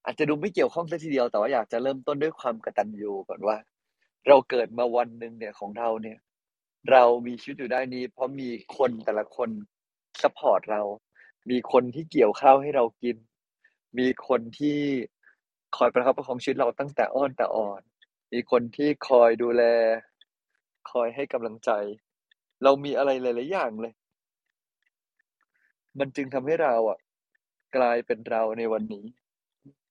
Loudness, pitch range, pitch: -25 LUFS, 115-135 Hz, 120 Hz